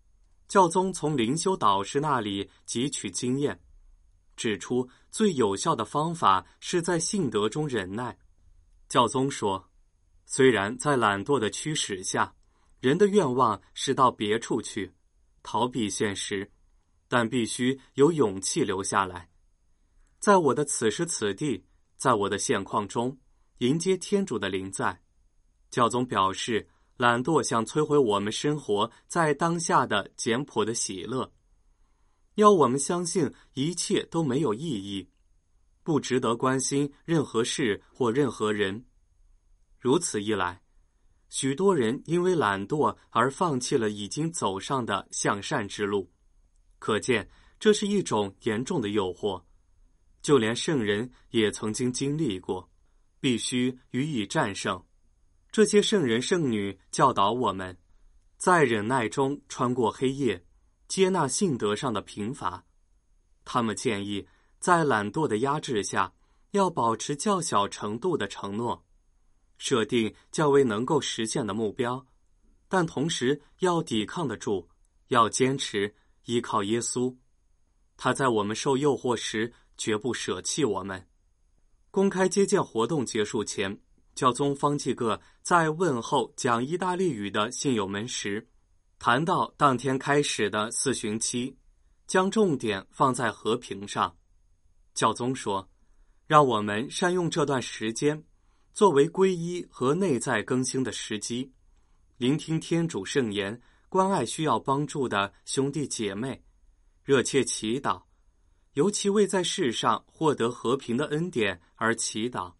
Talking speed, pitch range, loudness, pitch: 200 characters per minute, 95-145 Hz, -27 LUFS, 115 Hz